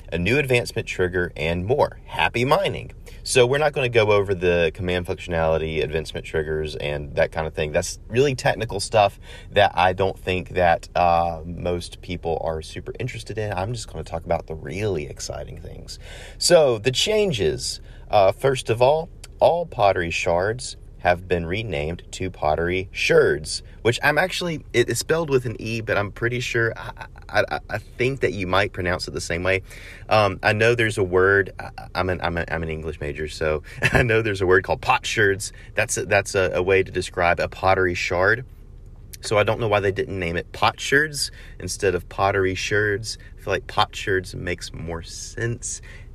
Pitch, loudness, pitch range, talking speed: 95 Hz, -22 LUFS, 90-115 Hz, 195 wpm